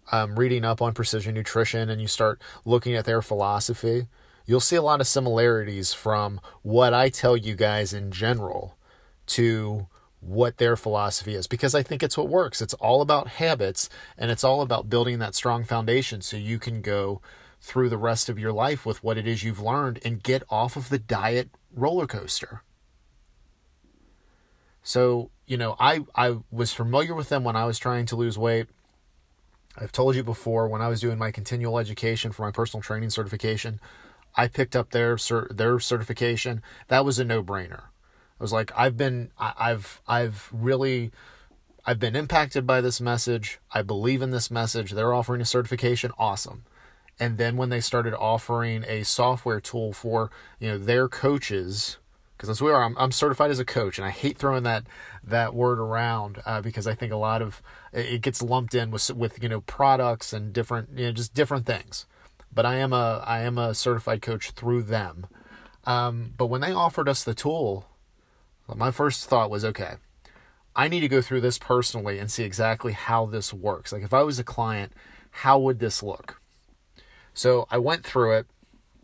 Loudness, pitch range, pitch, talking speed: -25 LUFS, 110-125 Hz, 115 Hz, 190 wpm